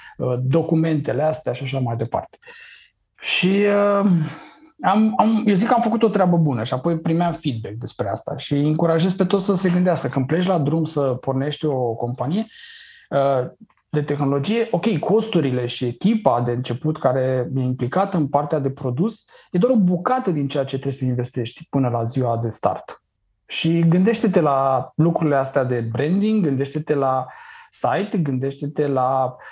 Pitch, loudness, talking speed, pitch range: 150 Hz, -20 LUFS, 165 wpm, 130-190 Hz